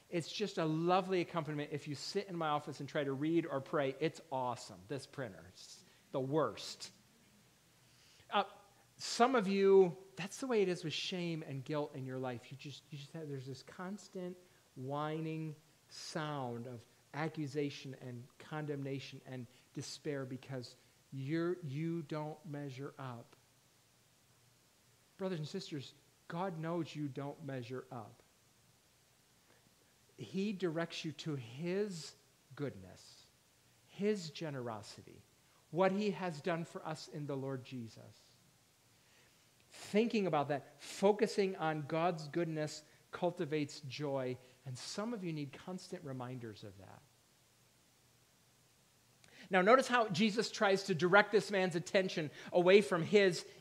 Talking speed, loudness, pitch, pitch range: 135 wpm, -37 LUFS, 150 Hz, 130-180 Hz